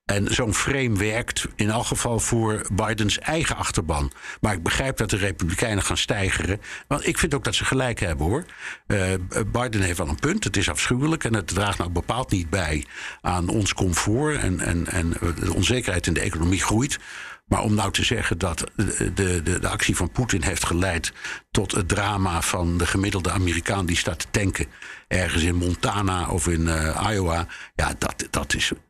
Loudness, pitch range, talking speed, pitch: -23 LUFS, 90-110 Hz, 190 wpm, 100 Hz